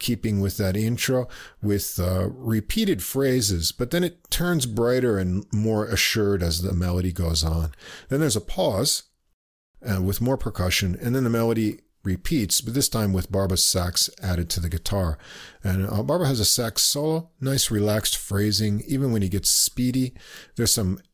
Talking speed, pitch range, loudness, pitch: 175 wpm, 95-125 Hz, -23 LUFS, 105 Hz